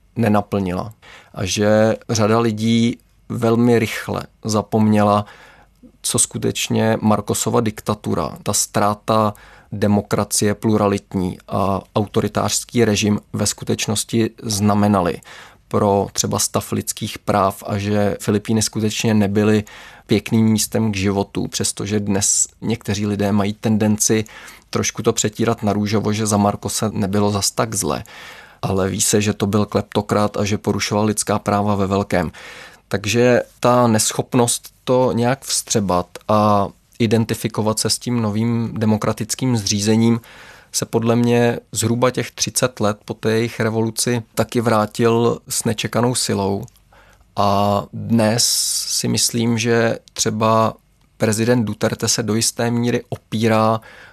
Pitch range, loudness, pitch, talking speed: 105-115 Hz, -18 LUFS, 110 Hz, 125 wpm